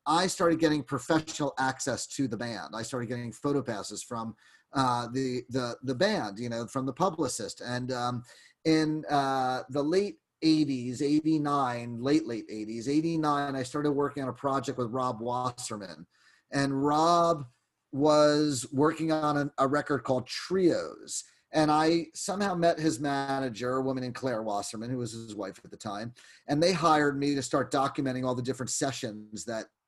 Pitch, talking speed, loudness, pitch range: 135 Hz, 170 wpm, -29 LUFS, 125-150 Hz